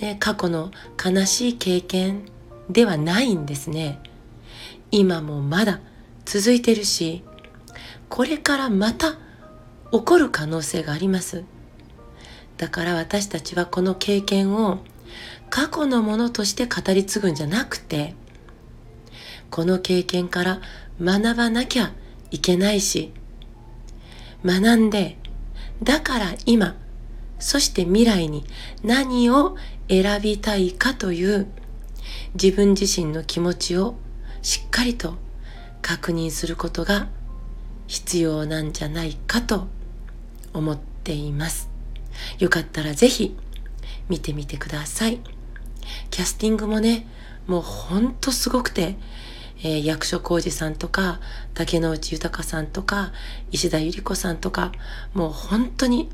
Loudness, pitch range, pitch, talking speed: -22 LUFS, 155-210 Hz, 180 Hz, 230 characters per minute